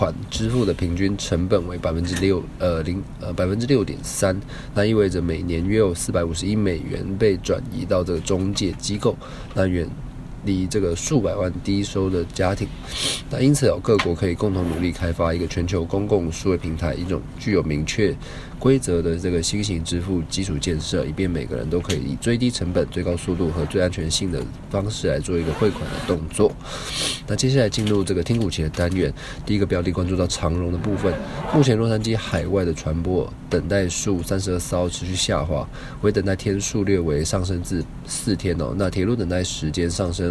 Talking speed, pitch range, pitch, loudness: 310 characters per minute, 85-100 Hz, 90 Hz, -22 LUFS